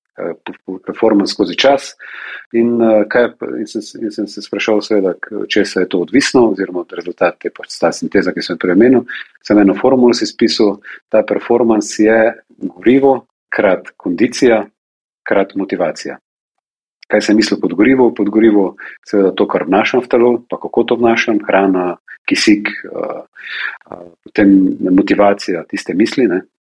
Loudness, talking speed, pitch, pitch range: -14 LUFS, 130 wpm, 105 Hz, 95-115 Hz